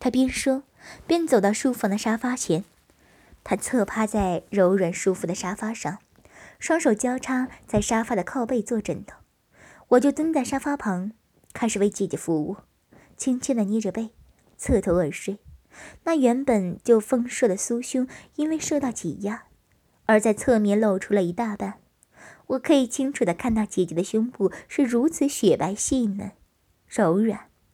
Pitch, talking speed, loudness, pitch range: 225 Hz, 235 characters per minute, -24 LUFS, 200-255 Hz